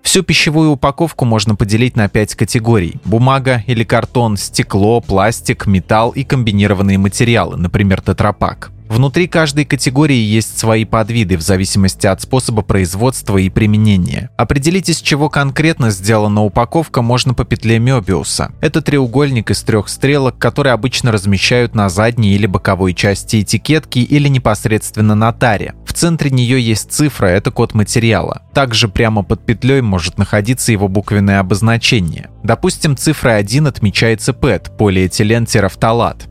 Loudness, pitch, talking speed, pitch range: -13 LUFS, 115 Hz, 135 wpm, 105-130 Hz